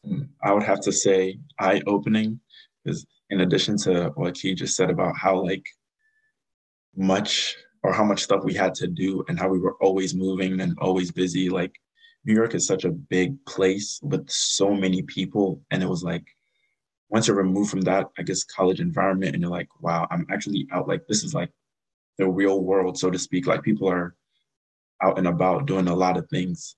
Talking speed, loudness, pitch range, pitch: 200 wpm, -24 LUFS, 95-100 Hz, 95 Hz